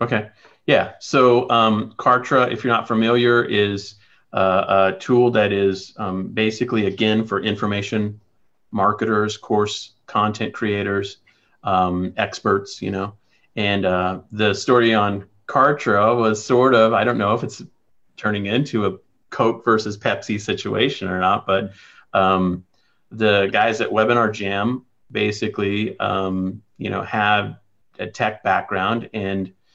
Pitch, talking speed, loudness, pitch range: 105 Hz, 135 wpm, -20 LUFS, 95-110 Hz